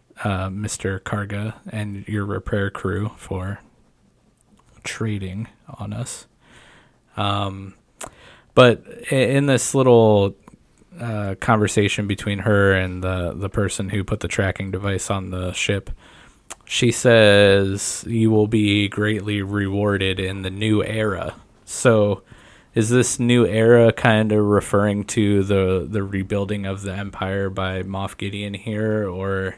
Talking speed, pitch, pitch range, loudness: 130 wpm, 100 Hz, 95-110 Hz, -20 LUFS